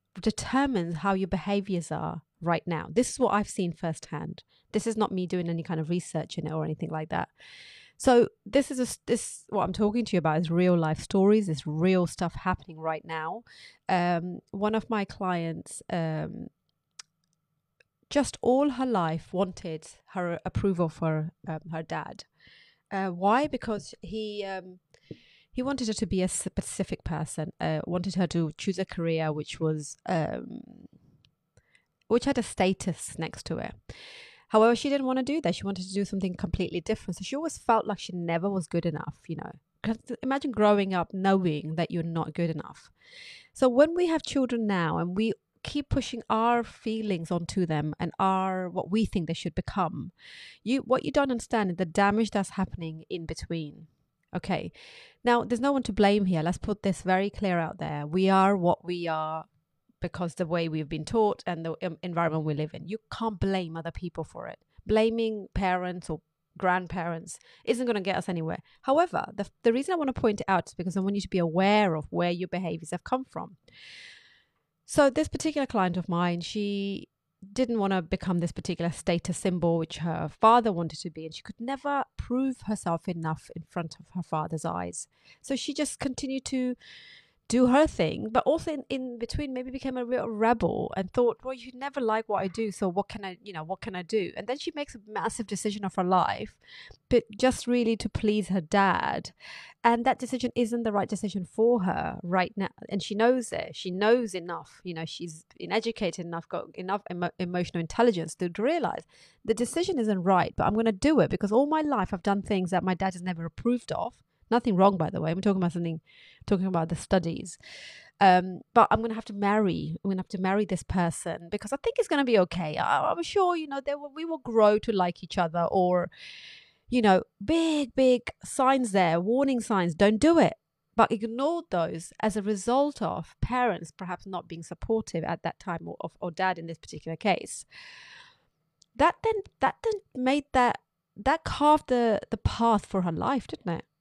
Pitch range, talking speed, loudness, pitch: 170-235 Hz, 200 wpm, -28 LUFS, 195 Hz